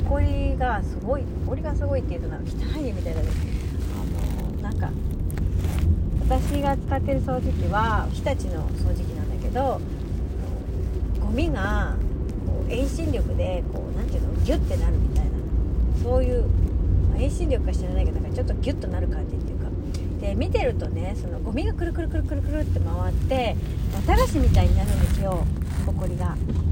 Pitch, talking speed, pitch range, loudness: 85 Hz, 315 characters per minute, 80-90 Hz, -25 LUFS